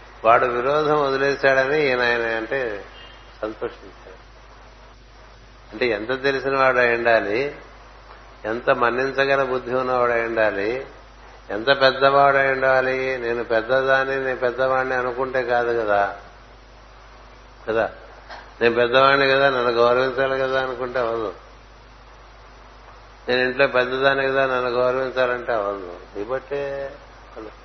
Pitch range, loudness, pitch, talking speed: 120-135 Hz, -20 LUFS, 130 Hz, 100 wpm